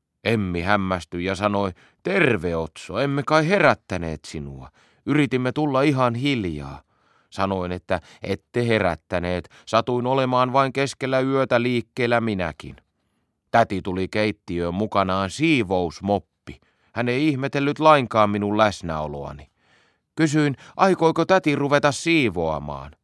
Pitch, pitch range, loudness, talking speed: 105 Hz, 90-135 Hz, -22 LUFS, 105 wpm